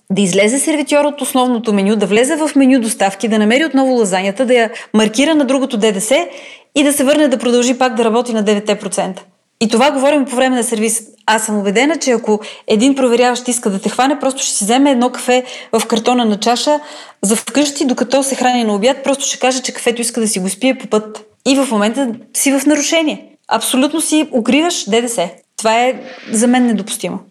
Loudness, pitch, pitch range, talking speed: -14 LUFS, 245 Hz, 220-275 Hz, 205 wpm